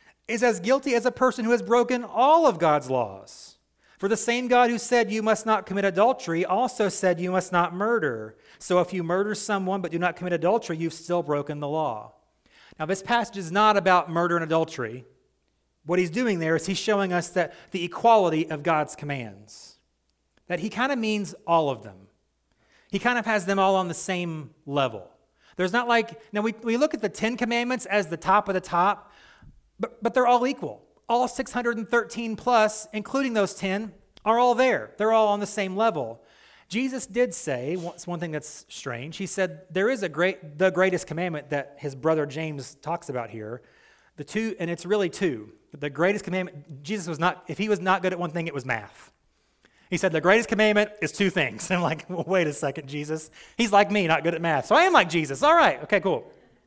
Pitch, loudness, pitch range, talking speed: 185 Hz, -24 LUFS, 160-220 Hz, 215 wpm